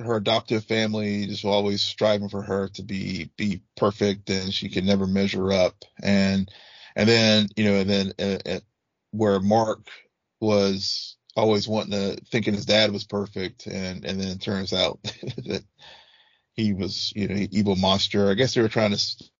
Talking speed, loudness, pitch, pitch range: 185 wpm, -24 LUFS, 100 Hz, 95-110 Hz